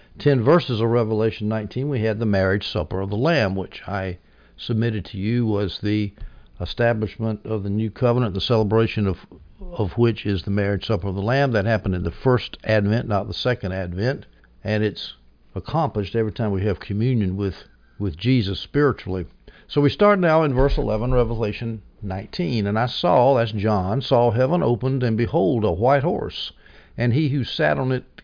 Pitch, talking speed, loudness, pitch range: 110 Hz, 185 wpm, -22 LUFS, 100-125 Hz